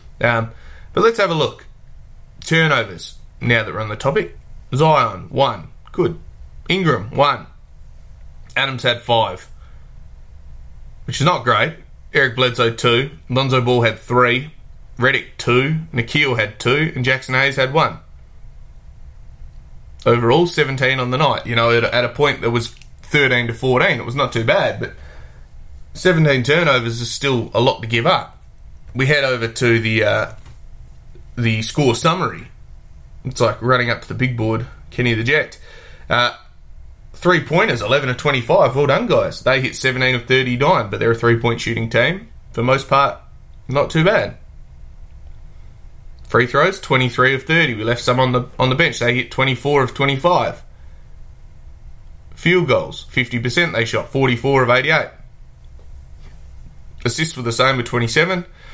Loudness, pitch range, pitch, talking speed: -17 LUFS, 115-135 Hz, 125 Hz, 165 wpm